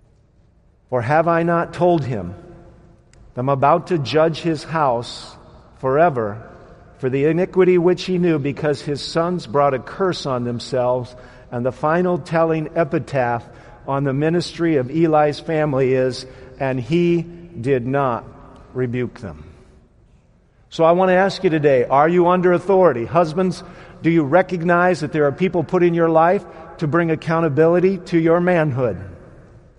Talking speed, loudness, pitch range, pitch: 150 wpm, -18 LUFS, 130-175 Hz, 160 Hz